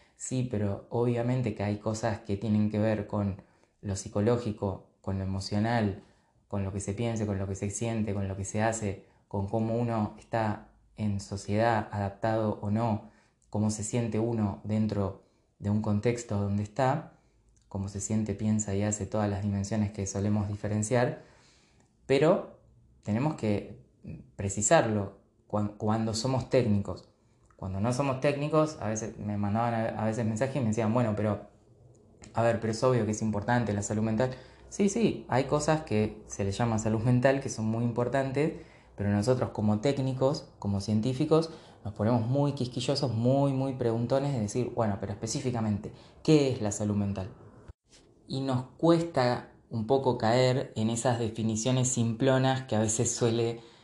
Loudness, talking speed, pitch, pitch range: -30 LUFS, 165 wpm, 110 Hz, 105-125 Hz